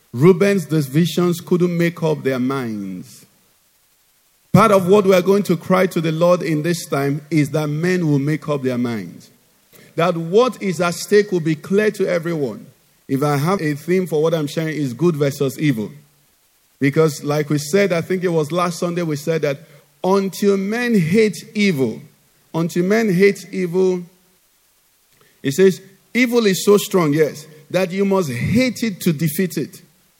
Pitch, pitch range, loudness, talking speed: 175 Hz, 150-190 Hz, -18 LUFS, 175 wpm